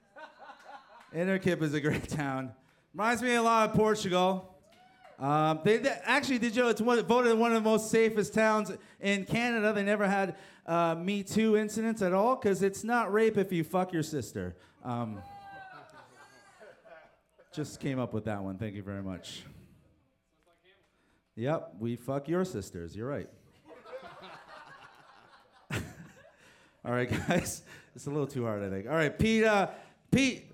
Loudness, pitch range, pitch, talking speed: -30 LUFS, 140-220 Hz, 190 Hz, 155 wpm